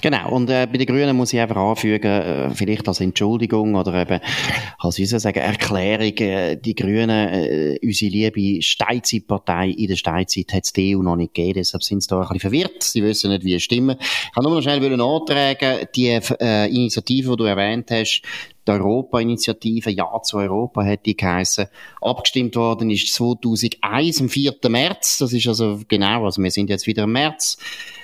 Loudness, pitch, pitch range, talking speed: -19 LUFS, 110 Hz, 100-120 Hz, 190 wpm